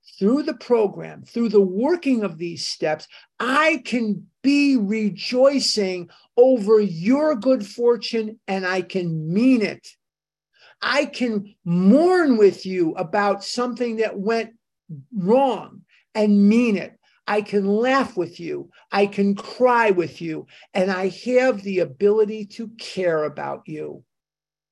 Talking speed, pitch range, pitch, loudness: 130 wpm, 185-245 Hz, 210 Hz, -20 LUFS